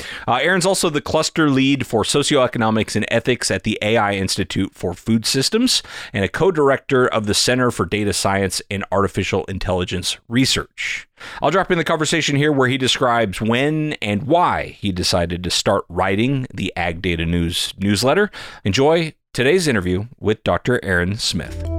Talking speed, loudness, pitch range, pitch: 165 wpm, -18 LUFS, 95-140 Hz, 115 Hz